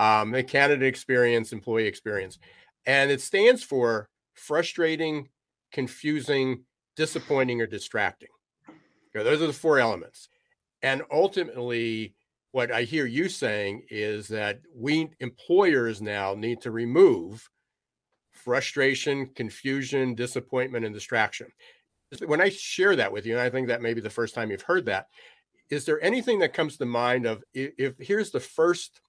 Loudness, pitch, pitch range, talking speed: -26 LUFS, 130 Hz, 115-150 Hz, 150 wpm